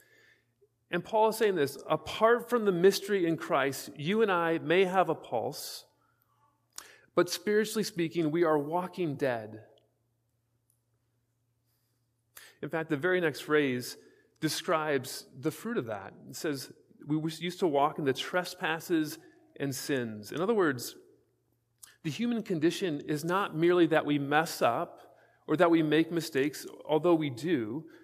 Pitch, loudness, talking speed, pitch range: 160 Hz, -30 LUFS, 145 wpm, 140-185 Hz